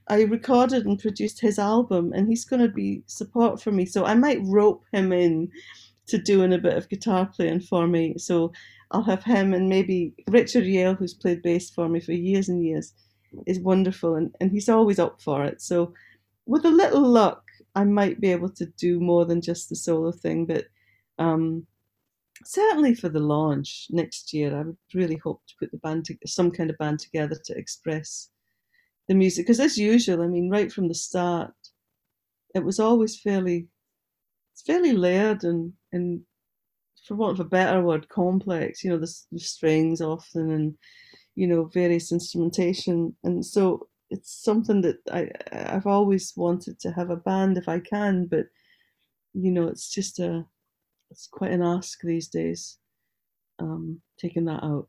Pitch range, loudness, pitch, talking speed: 165-200 Hz, -24 LUFS, 175 Hz, 180 wpm